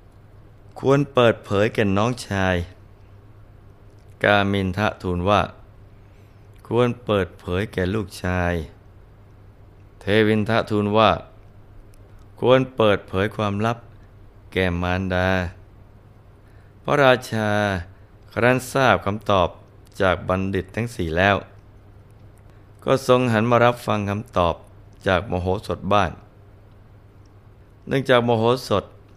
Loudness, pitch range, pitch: -21 LUFS, 100-105 Hz, 100 Hz